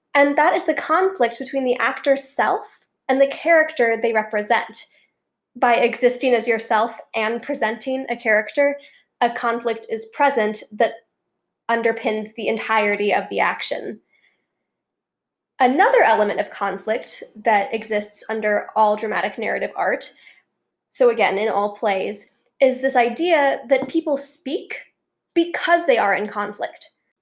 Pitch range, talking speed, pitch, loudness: 220-280 Hz, 130 wpm, 235 Hz, -20 LUFS